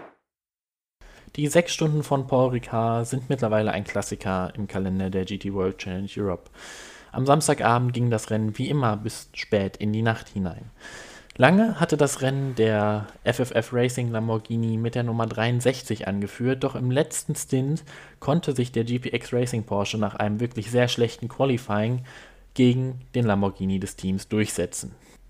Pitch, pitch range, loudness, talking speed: 115 Hz, 105-130 Hz, -25 LUFS, 155 wpm